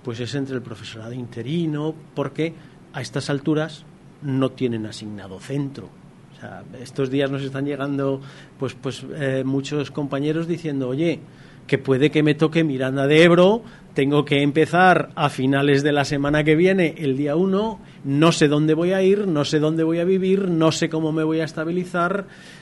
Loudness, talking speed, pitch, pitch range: -21 LUFS, 180 wpm, 150 Hz, 135-165 Hz